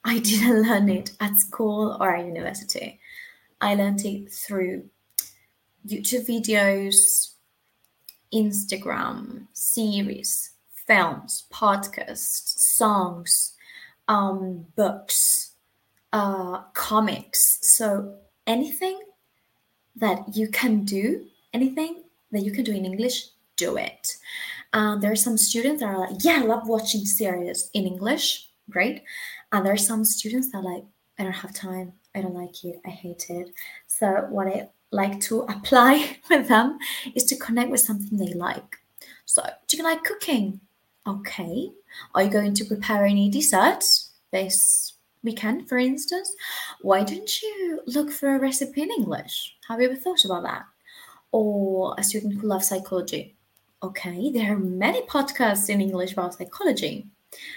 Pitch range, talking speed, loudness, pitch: 195-265 Hz, 140 wpm, -23 LUFS, 215 Hz